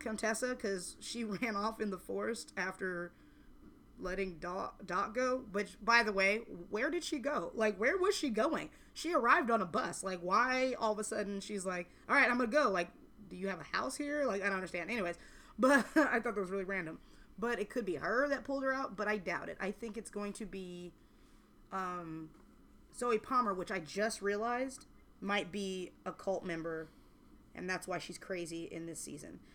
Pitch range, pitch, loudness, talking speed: 185-245 Hz, 205 Hz, -36 LUFS, 205 wpm